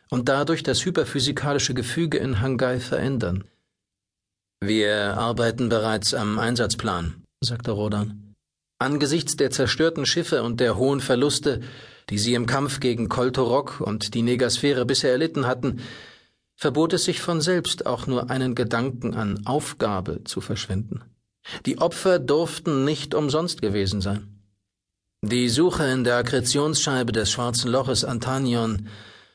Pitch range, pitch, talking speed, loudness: 105-140 Hz, 125 Hz, 130 wpm, -23 LUFS